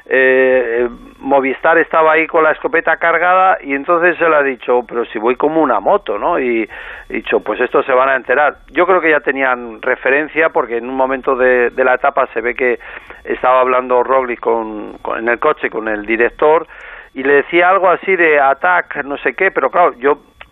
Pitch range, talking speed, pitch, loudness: 125-165 Hz, 210 wpm, 135 Hz, -13 LUFS